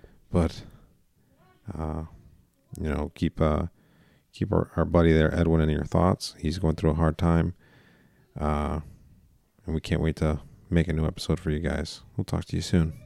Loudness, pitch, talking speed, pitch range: -27 LUFS, 80 Hz, 180 wpm, 75-85 Hz